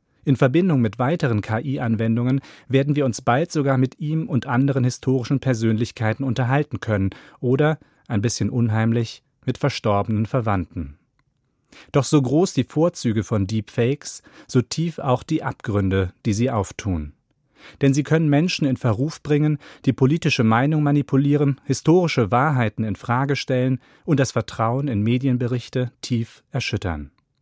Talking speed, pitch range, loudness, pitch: 140 wpm, 115-145 Hz, -21 LUFS, 130 Hz